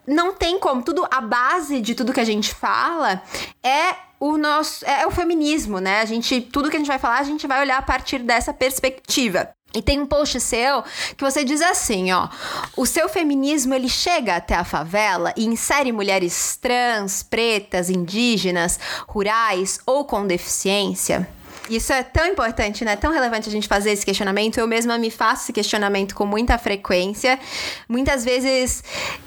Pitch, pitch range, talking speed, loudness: 245 Hz, 210-280 Hz, 175 wpm, -20 LUFS